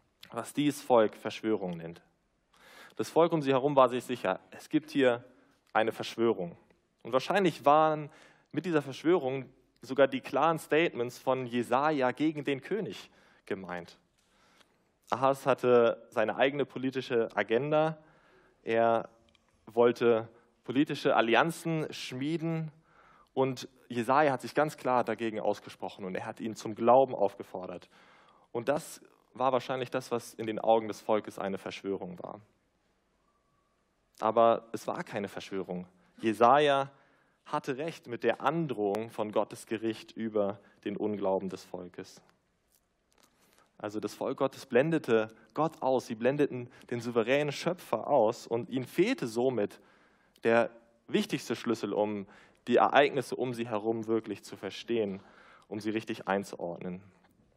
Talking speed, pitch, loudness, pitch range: 130 wpm, 120 Hz, -30 LUFS, 110-135 Hz